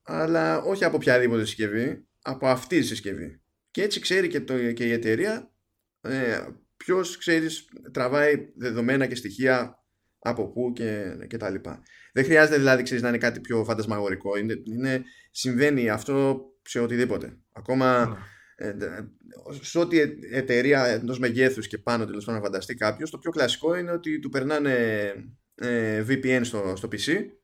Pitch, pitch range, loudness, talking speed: 125 Hz, 110-135 Hz, -25 LUFS, 150 wpm